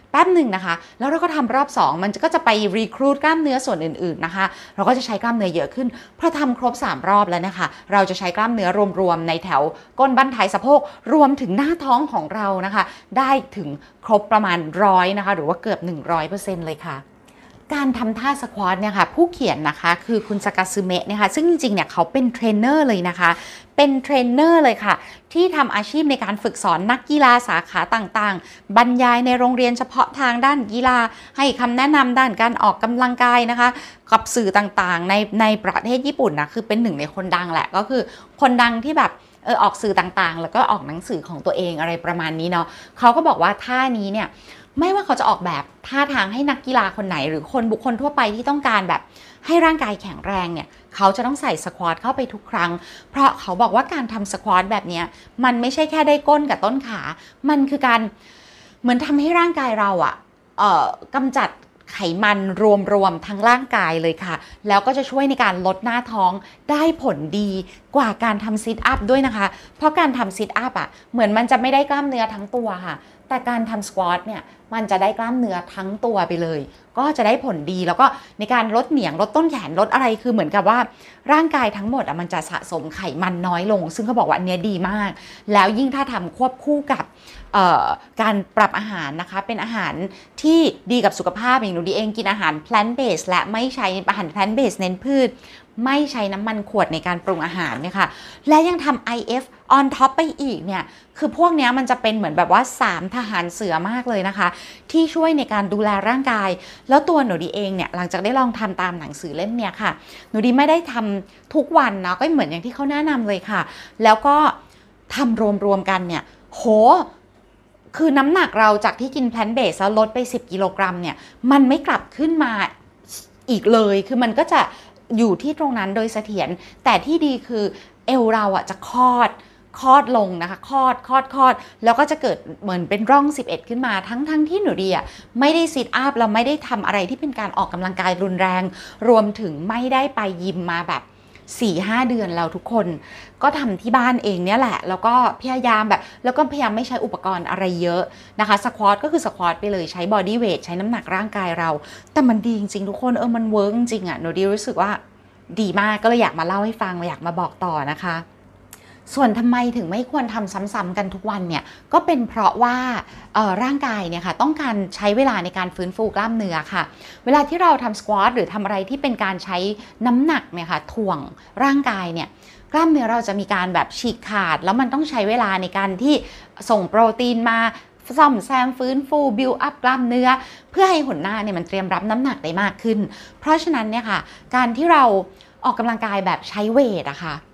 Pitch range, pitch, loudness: 190-260 Hz, 220 Hz, -19 LUFS